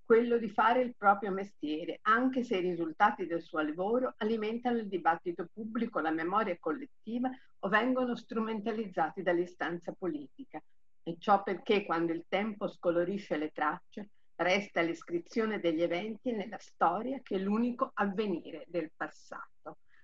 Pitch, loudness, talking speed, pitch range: 205 Hz, -33 LUFS, 140 wpm, 175-230 Hz